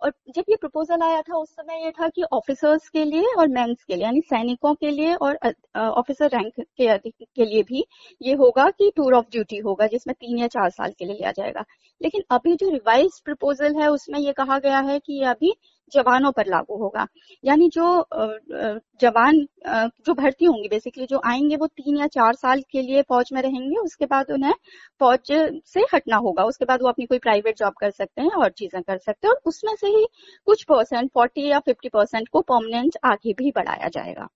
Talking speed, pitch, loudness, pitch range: 205 wpm, 275 Hz, -21 LUFS, 235-320 Hz